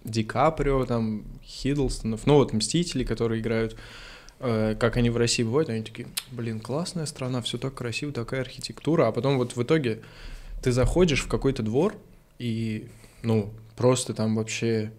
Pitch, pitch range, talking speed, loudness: 120 Hz, 115-135 Hz, 160 wpm, -26 LUFS